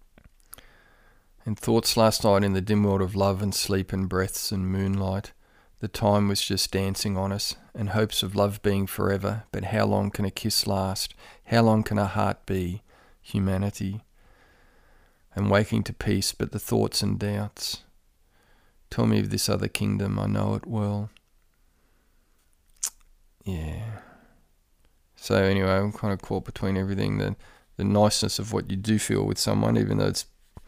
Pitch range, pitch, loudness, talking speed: 95-105 Hz, 100 Hz, -26 LUFS, 165 wpm